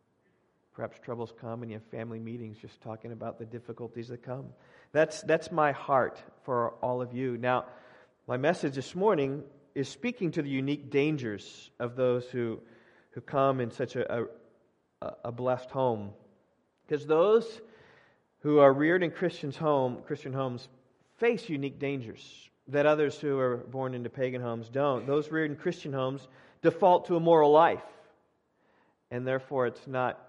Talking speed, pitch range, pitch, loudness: 160 wpm, 120-150 Hz, 135 Hz, -29 LUFS